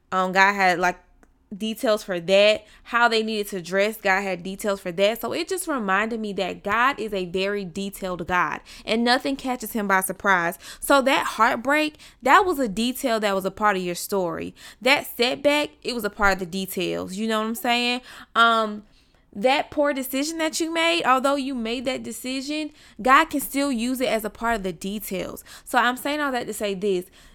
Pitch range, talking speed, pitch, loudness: 195-265 Hz, 205 wpm, 220 Hz, -23 LUFS